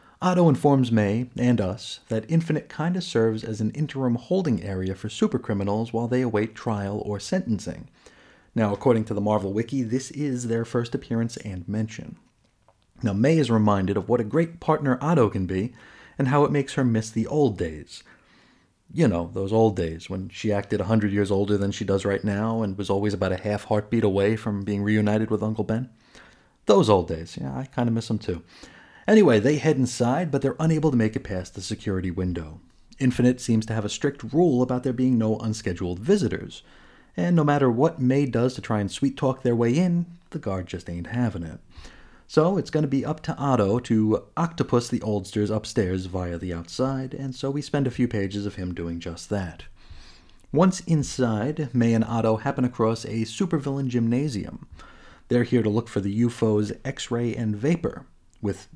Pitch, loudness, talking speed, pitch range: 115 Hz, -24 LUFS, 195 wpm, 105-135 Hz